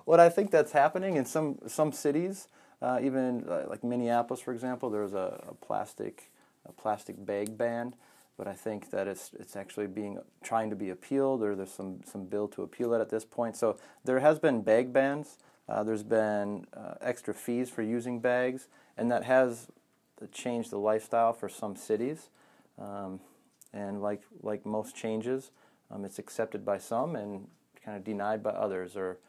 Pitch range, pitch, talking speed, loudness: 105-125 Hz, 115 Hz, 180 wpm, -32 LUFS